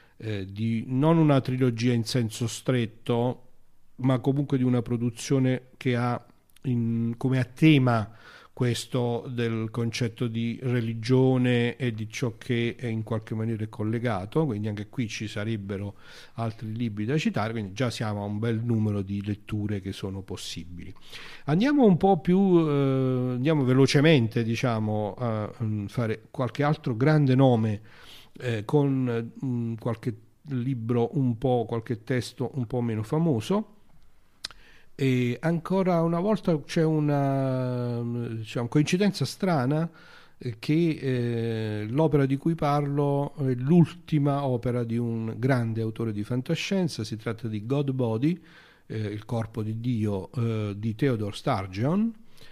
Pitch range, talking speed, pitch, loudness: 115-140 Hz, 135 wpm, 125 Hz, -26 LUFS